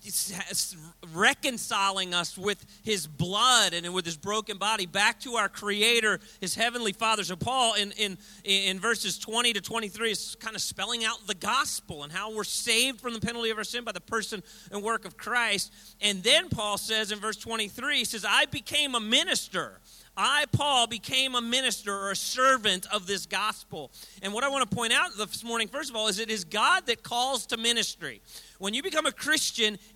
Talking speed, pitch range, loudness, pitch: 200 wpm, 195-235 Hz, -27 LUFS, 215 Hz